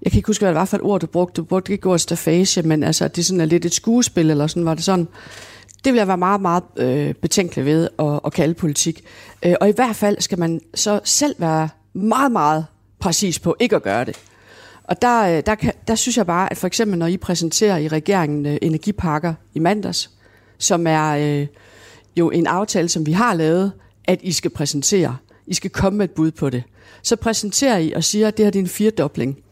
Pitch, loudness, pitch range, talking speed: 170 Hz, -18 LUFS, 155-200 Hz, 225 wpm